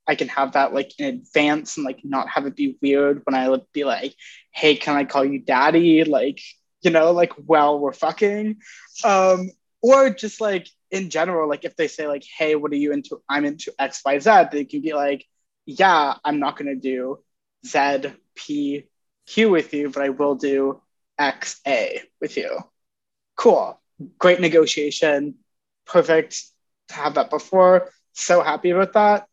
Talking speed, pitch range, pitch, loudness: 180 wpm, 140-180 Hz, 150 Hz, -20 LUFS